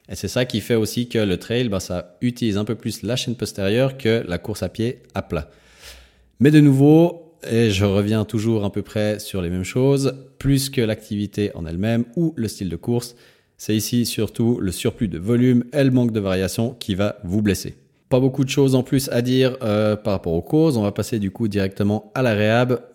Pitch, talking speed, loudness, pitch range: 110 Hz, 225 wpm, -20 LUFS, 100-125 Hz